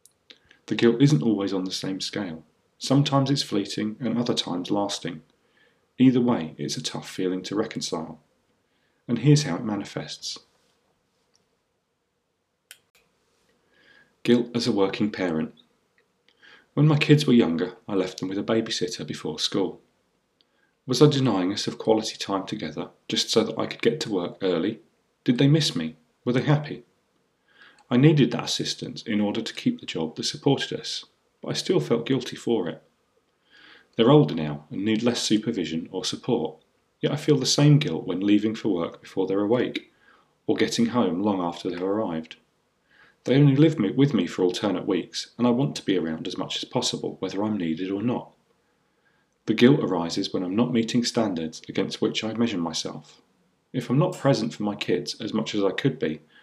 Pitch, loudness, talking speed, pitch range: 115 Hz, -24 LUFS, 180 wpm, 95-130 Hz